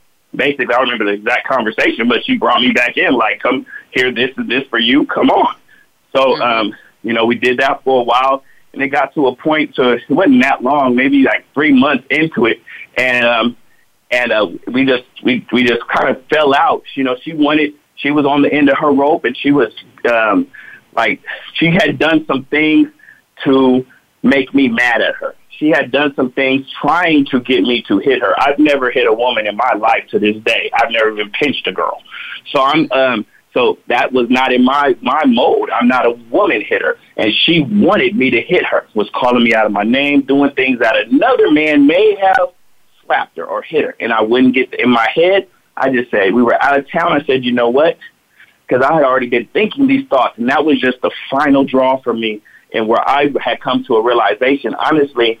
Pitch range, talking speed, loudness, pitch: 125-160 Hz, 225 wpm, -13 LUFS, 135 Hz